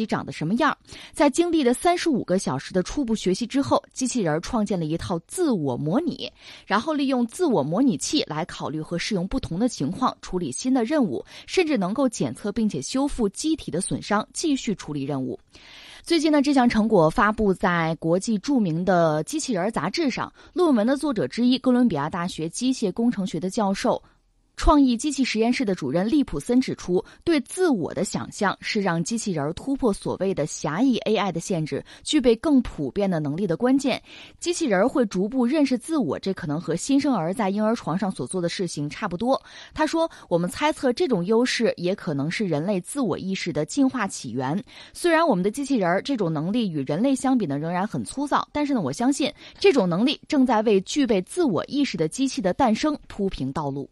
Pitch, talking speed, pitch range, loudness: 220 Hz, 310 characters per minute, 180-275 Hz, -24 LUFS